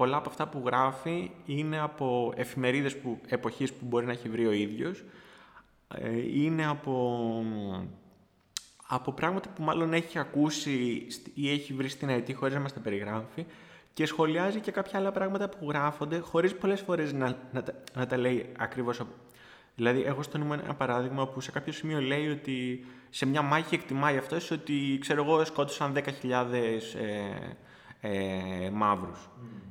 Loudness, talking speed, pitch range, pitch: -31 LUFS, 155 wpm, 120-150 Hz, 135 Hz